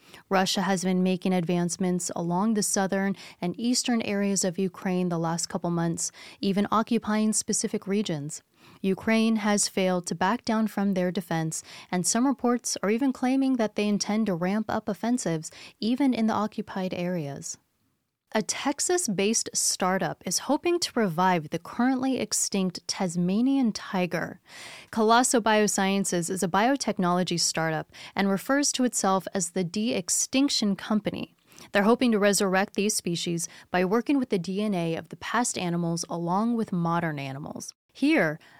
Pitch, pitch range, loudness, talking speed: 195 Hz, 180-225 Hz, -26 LUFS, 145 wpm